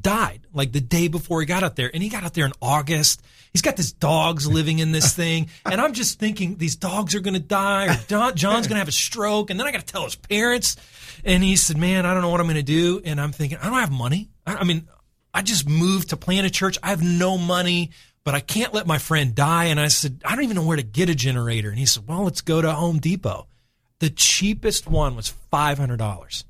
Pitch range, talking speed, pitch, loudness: 145-190 Hz, 260 wpm, 165 Hz, -21 LUFS